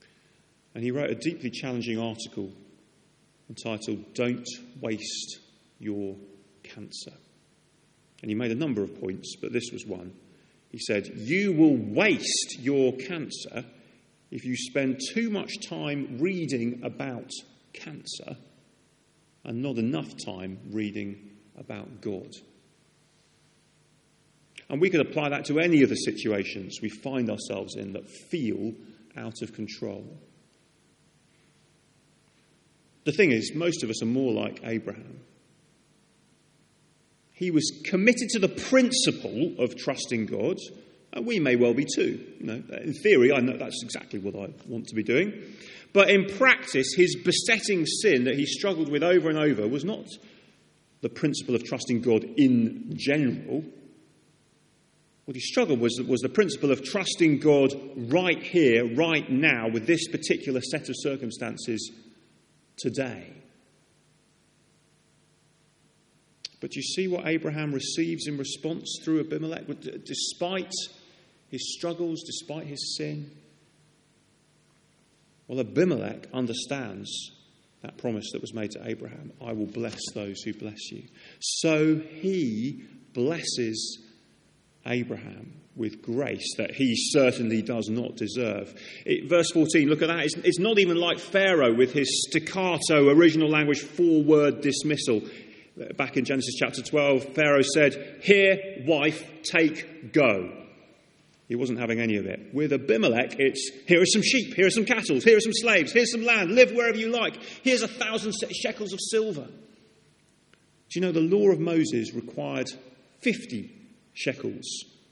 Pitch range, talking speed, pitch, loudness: 120-175 Hz, 140 wpm, 145 Hz, -26 LUFS